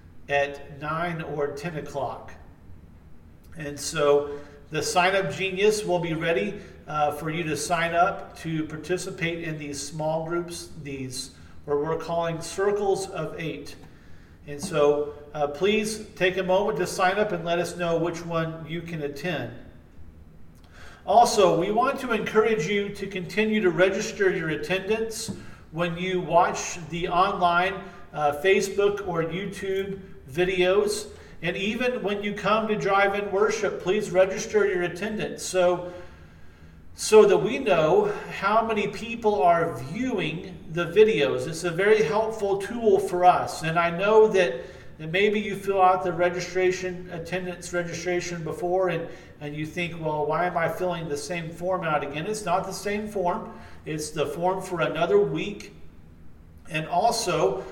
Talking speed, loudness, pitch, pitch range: 150 wpm, -25 LUFS, 175 Hz, 150-195 Hz